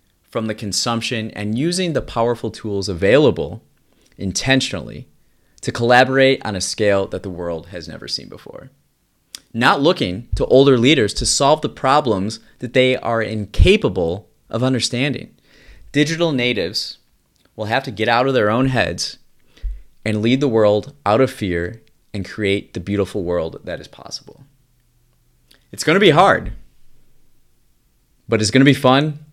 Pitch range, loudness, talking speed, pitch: 100-130 Hz, -17 LUFS, 145 wpm, 115 Hz